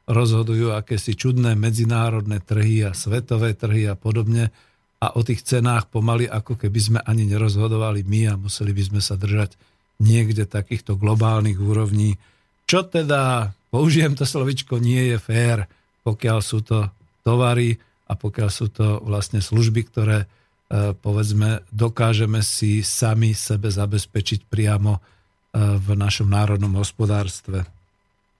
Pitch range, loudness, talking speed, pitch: 105-115 Hz, -21 LUFS, 130 wpm, 110 Hz